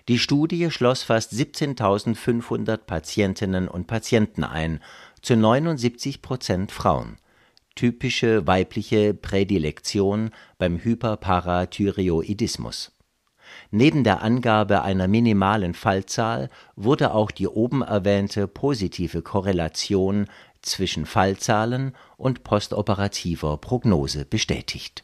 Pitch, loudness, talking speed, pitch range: 105 Hz, -23 LUFS, 85 wpm, 95-120 Hz